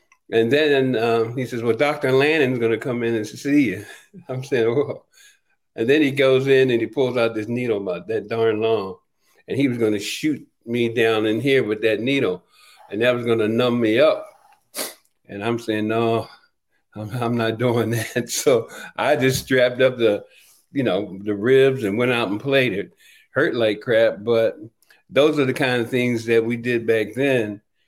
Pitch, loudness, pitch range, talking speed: 120 Hz, -20 LUFS, 115-135 Hz, 200 wpm